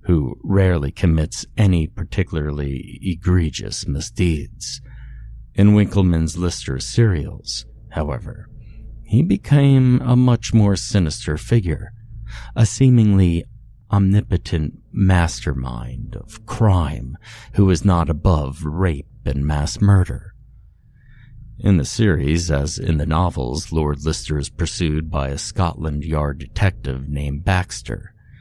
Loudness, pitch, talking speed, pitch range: -19 LUFS, 90 Hz, 110 wpm, 75-110 Hz